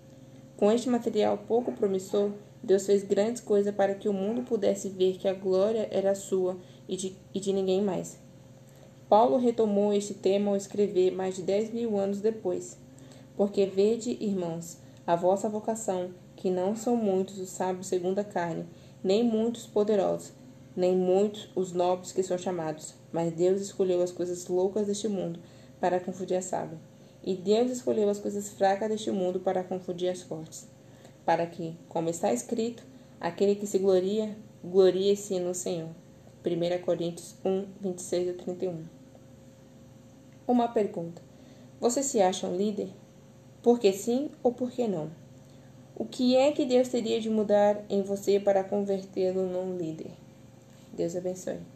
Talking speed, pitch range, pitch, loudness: 150 wpm, 175-205 Hz, 190 Hz, -29 LUFS